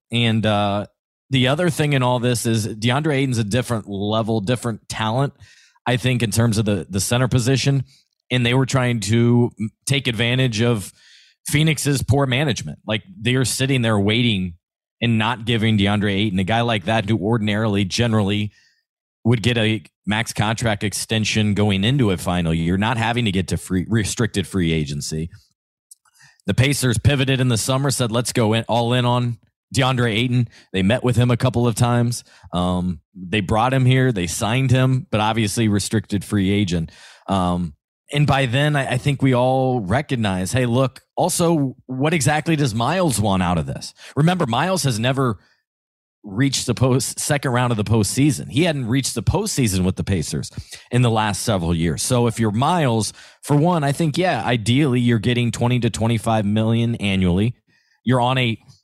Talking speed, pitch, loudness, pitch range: 180 wpm, 120 Hz, -19 LUFS, 105-130 Hz